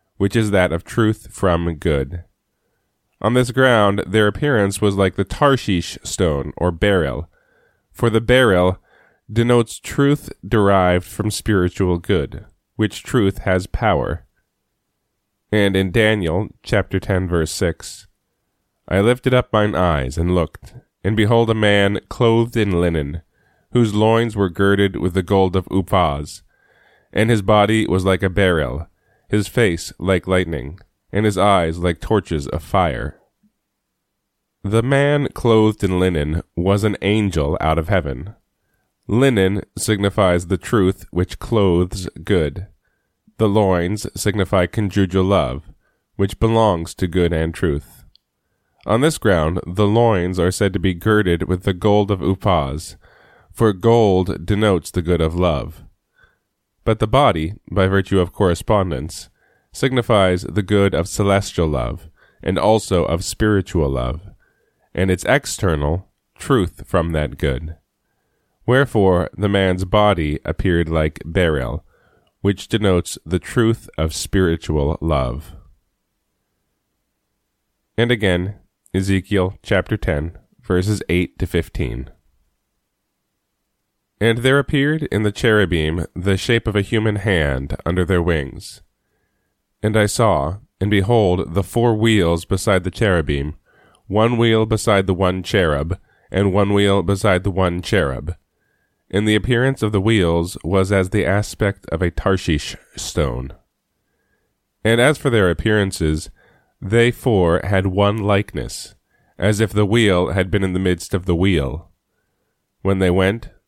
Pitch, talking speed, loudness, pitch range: 95 Hz, 135 wpm, -18 LUFS, 85-105 Hz